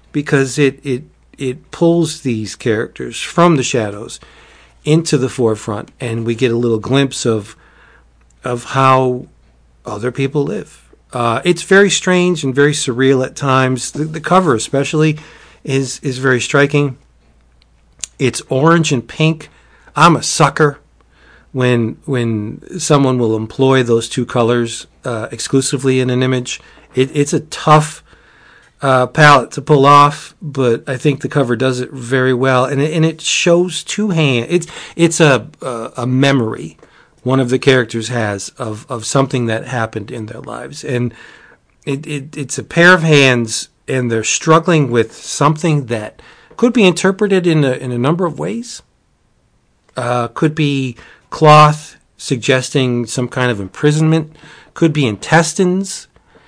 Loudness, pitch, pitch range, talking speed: -14 LUFS, 135 Hz, 120-155 Hz, 150 wpm